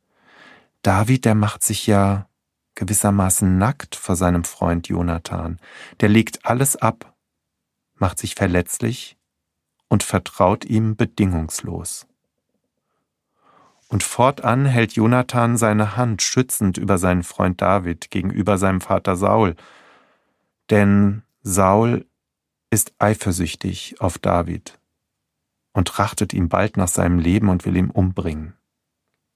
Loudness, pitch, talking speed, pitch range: -19 LUFS, 100 Hz, 110 wpm, 90-110 Hz